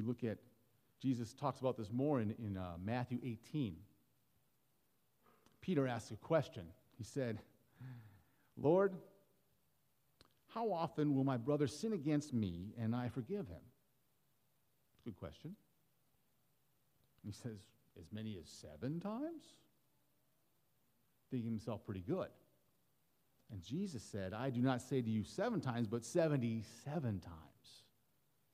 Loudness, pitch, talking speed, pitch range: -41 LUFS, 125 Hz, 125 wpm, 110-145 Hz